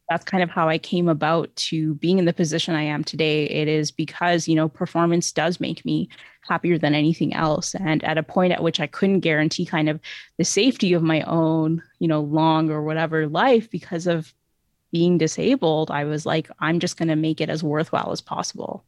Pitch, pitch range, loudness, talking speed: 160 Hz, 155-170 Hz, -22 LUFS, 215 wpm